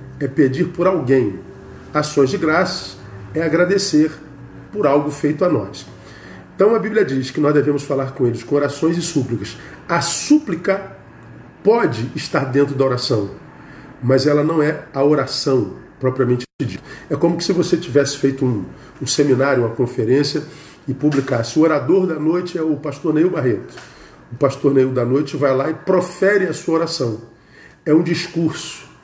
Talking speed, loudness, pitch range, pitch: 165 wpm, -18 LUFS, 135-165 Hz, 145 Hz